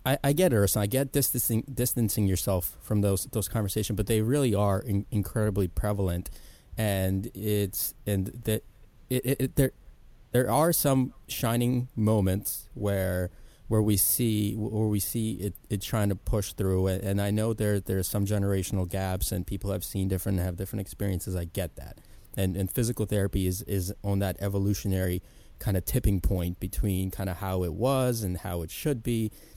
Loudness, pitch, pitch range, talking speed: -28 LUFS, 100 Hz, 95-110 Hz, 180 wpm